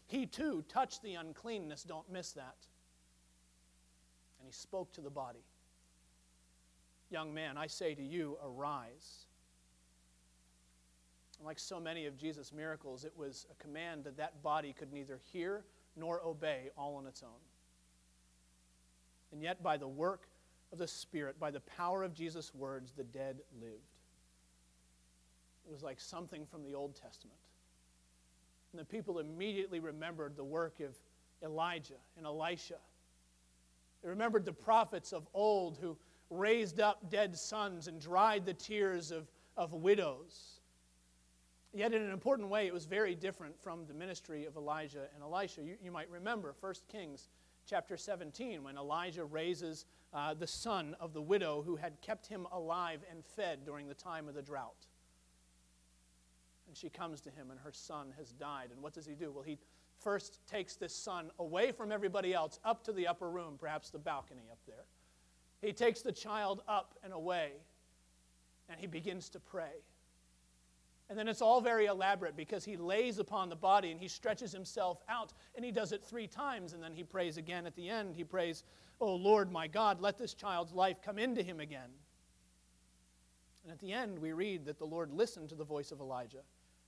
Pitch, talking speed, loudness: 155 Hz, 175 wpm, -40 LUFS